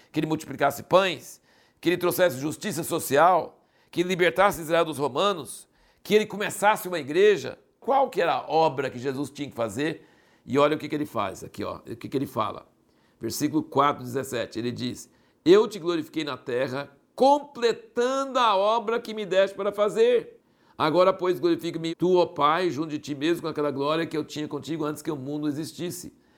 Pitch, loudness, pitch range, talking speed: 165 Hz, -25 LUFS, 150-205 Hz, 190 wpm